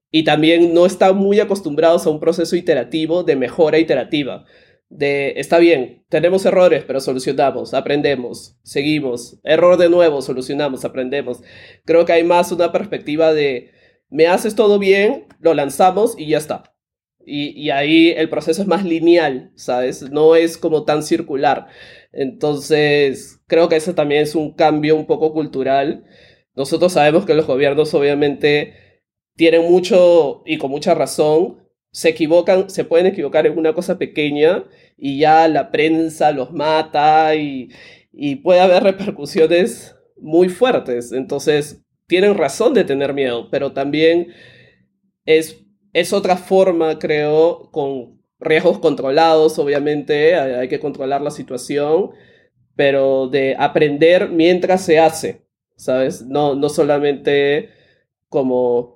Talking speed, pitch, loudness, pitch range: 140 wpm, 155 Hz, -15 LUFS, 145-175 Hz